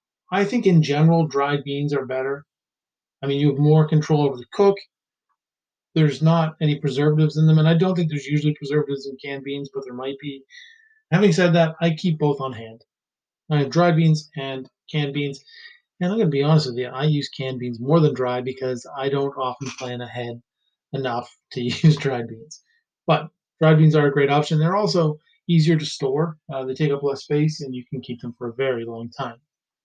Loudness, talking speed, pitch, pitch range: -21 LUFS, 215 wpm, 145 Hz, 135-160 Hz